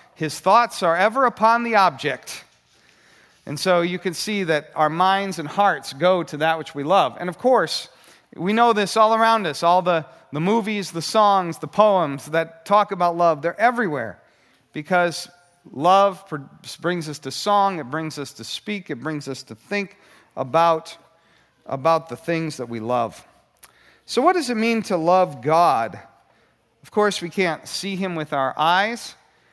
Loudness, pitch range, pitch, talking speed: -20 LUFS, 155-200 Hz, 175 Hz, 175 wpm